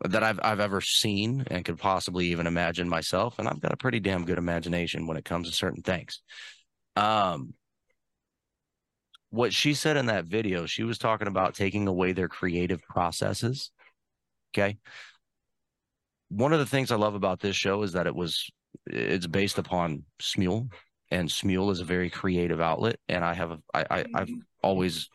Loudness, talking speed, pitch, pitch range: -28 LUFS, 175 wpm, 95 Hz, 90-110 Hz